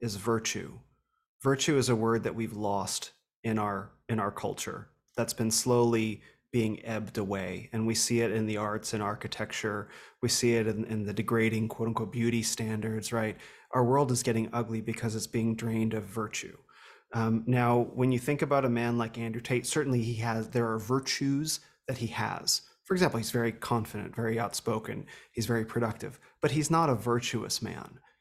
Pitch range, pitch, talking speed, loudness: 110-120 Hz, 115 Hz, 185 wpm, -30 LUFS